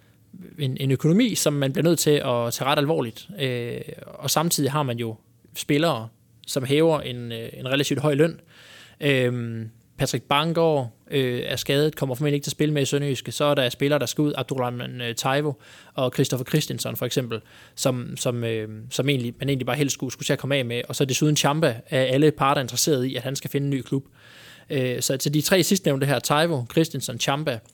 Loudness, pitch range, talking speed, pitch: -23 LUFS, 125-150 Hz, 215 wpm, 140 Hz